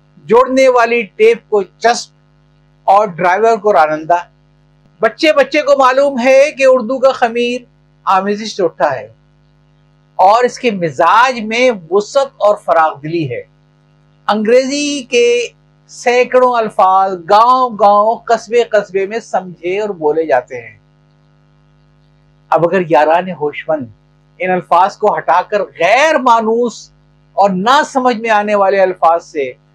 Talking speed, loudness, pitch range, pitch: 125 wpm, -12 LUFS, 150-240 Hz, 195 Hz